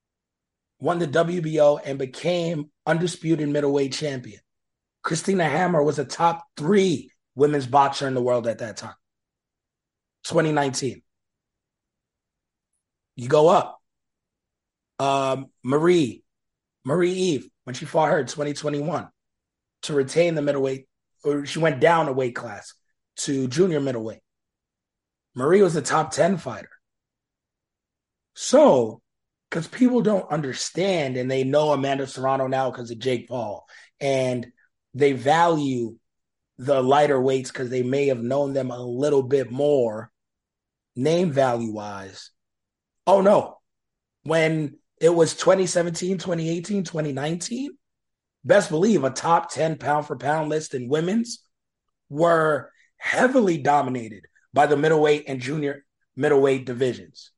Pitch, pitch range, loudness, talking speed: 145 Hz, 130-165 Hz, -22 LUFS, 130 wpm